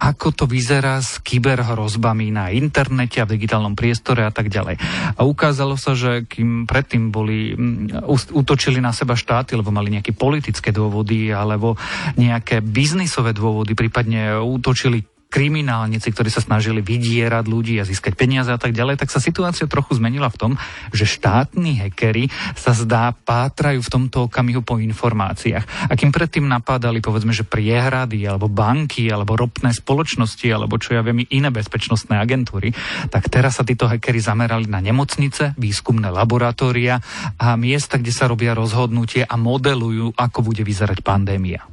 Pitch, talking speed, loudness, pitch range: 120 Hz, 155 wpm, -18 LUFS, 110-130 Hz